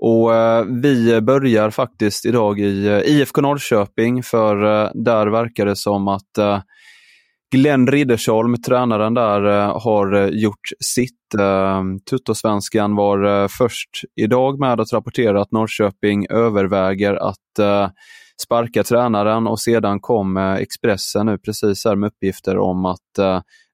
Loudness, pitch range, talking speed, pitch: -17 LUFS, 100-120 Hz, 115 wpm, 110 Hz